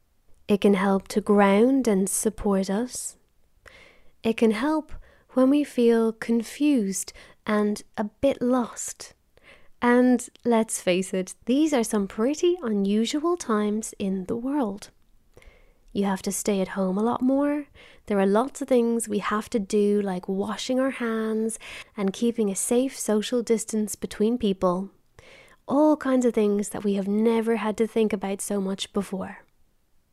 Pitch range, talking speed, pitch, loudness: 205-250 Hz, 155 wpm, 220 Hz, -24 LUFS